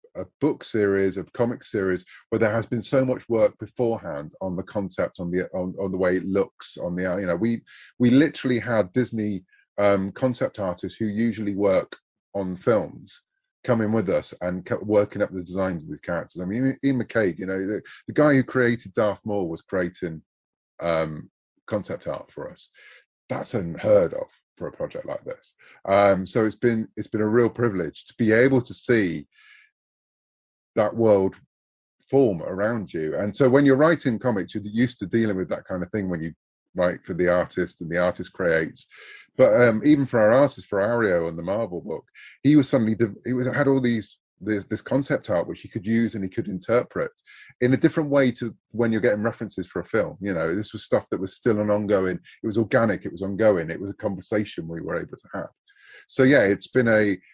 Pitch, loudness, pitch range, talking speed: 110 Hz, -24 LUFS, 95-125 Hz, 210 wpm